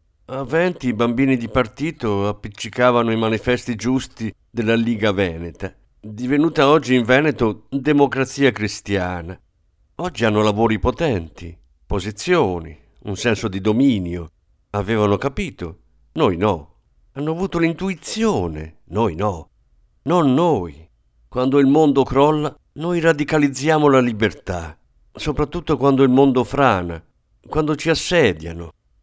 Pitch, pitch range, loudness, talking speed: 120 Hz, 95-140 Hz, -19 LUFS, 115 wpm